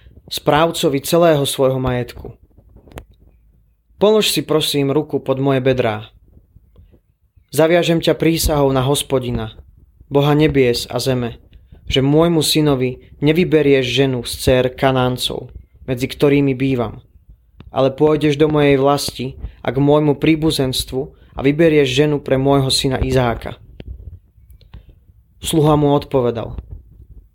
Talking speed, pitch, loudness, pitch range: 110 wpm, 135 Hz, -16 LUFS, 110-145 Hz